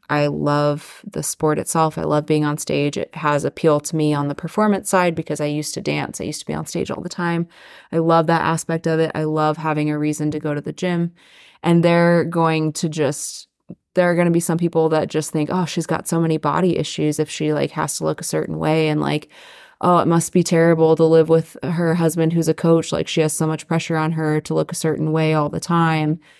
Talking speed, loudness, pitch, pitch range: 250 wpm, -19 LUFS, 160 Hz, 150-170 Hz